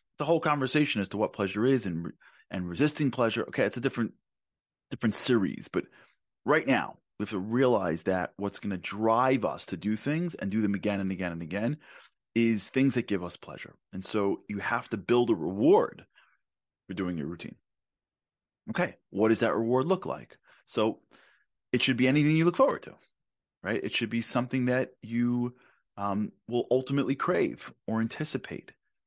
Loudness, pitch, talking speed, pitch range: -29 LUFS, 115 Hz, 185 wpm, 100-130 Hz